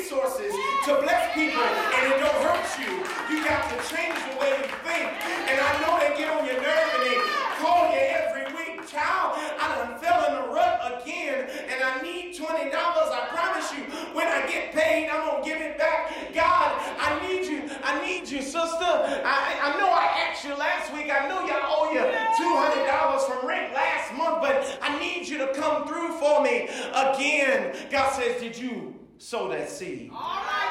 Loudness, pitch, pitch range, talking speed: -25 LUFS, 305 Hz, 275-330 Hz, 195 wpm